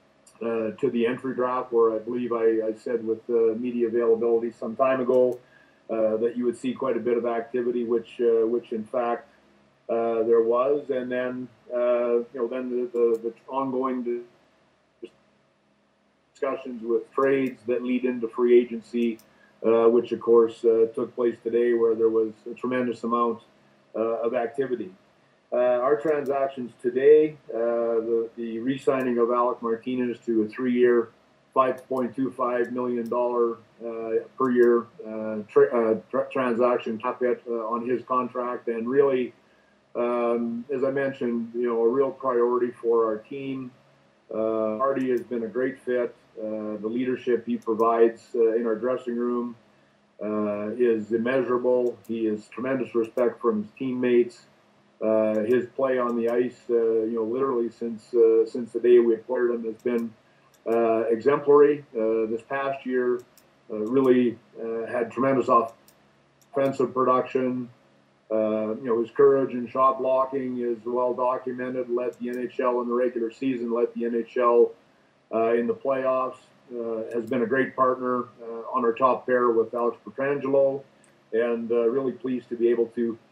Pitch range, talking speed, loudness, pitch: 115-125 Hz, 160 wpm, -25 LUFS, 120 Hz